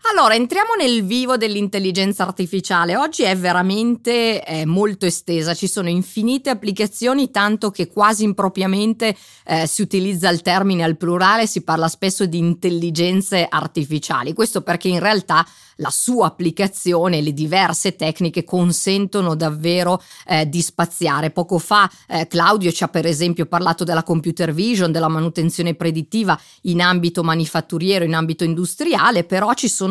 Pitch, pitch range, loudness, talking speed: 180 Hz, 170-205 Hz, -18 LUFS, 145 wpm